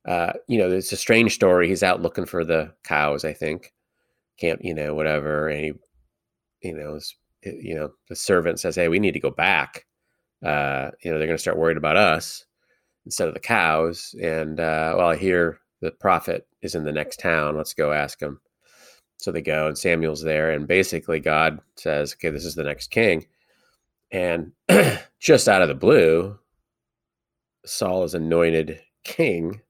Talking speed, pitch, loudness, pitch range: 185 wpm, 80 Hz, -22 LUFS, 75-85 Hz